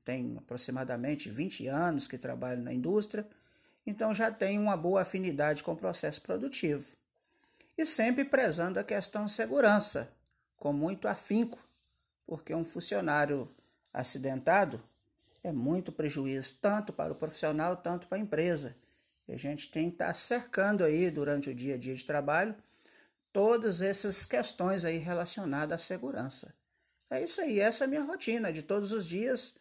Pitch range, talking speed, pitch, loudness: 150-220 Hz, 155 wpm, 185 Hz, -31 LUFS